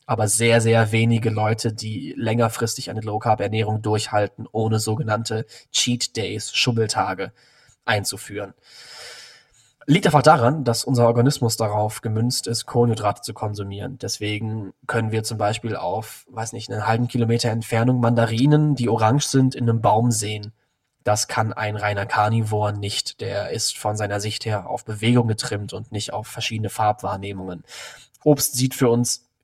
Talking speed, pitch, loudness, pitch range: 150 wpm, 115 Hz, -21 LUFS, 110-125 Hz